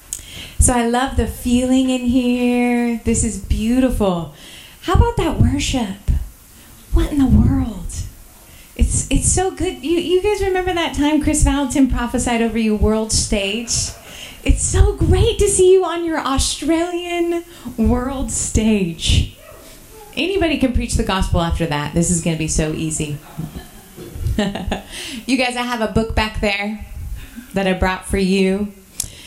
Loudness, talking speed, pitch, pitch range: -18 LUFS, 150 wpm, 245 Hz, 195-295 Hz